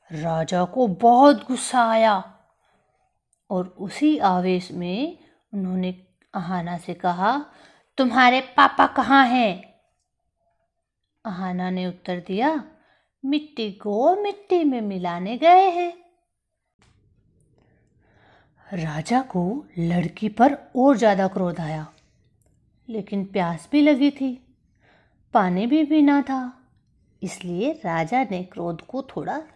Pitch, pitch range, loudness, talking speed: 215 Hz, 180-275 Hz, -21 LUFS, 105 wpm